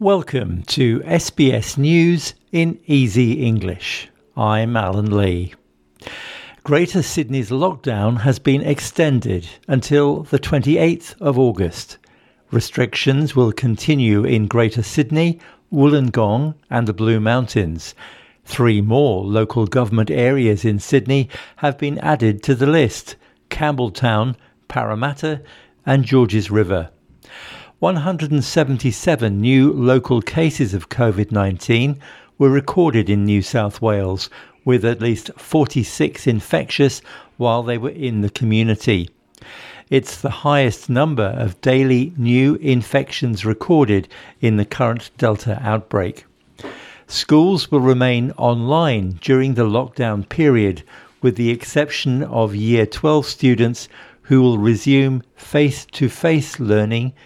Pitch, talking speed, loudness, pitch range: 125 Hz, 115 wpm, -17 LUFS, 110-145 Hz